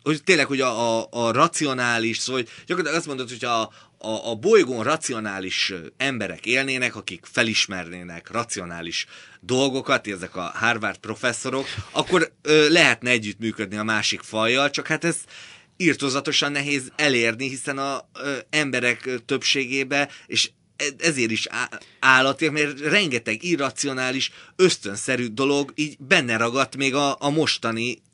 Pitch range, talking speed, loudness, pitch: 115-145 Hz, 130 wpm, -22 LUFS, 130 Hz